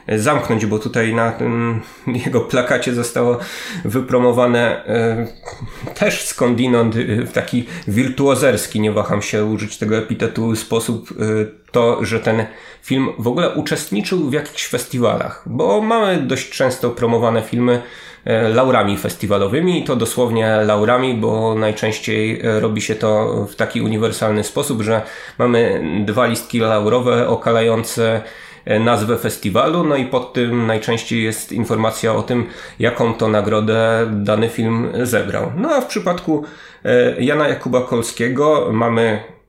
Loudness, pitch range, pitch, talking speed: -17 LUFS, 110-125 Hz, 115 Hz, 125 wpm